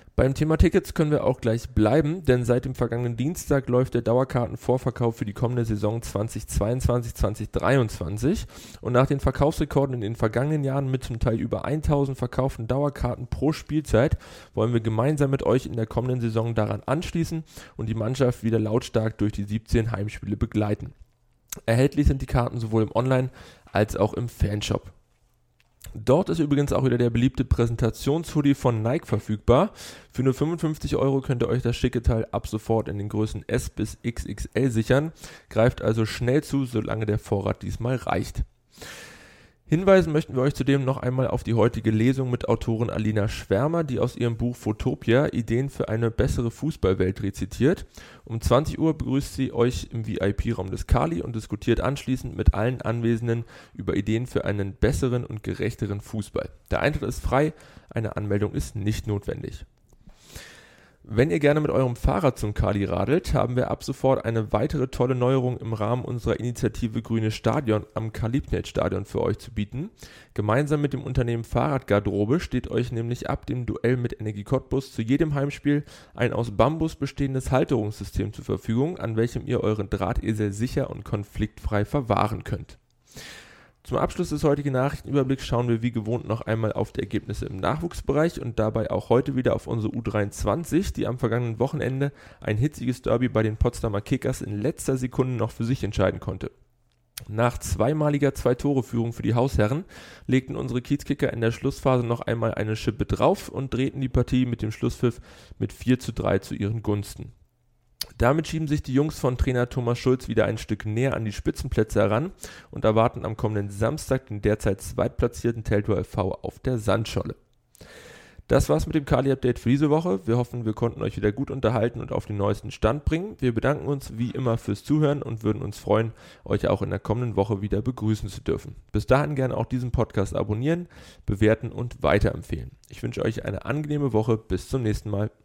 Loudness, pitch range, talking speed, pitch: -25 LUFS, 110-130 Hz, 175 wpm, 120 Hz